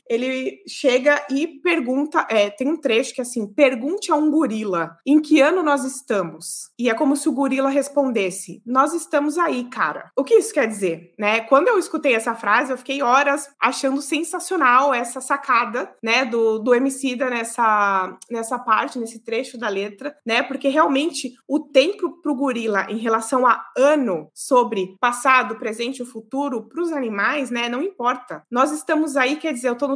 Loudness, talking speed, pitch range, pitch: -20 LUFS, 180 wpm, 230-290 Hz, 260 Hz